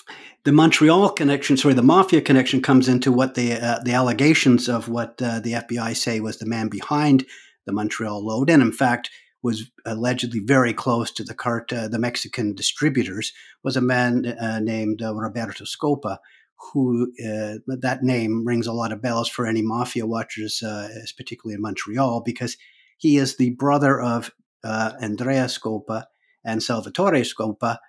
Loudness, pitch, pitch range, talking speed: -21 LUFS, 120 Hz, 110-130 Hz, 170 wpm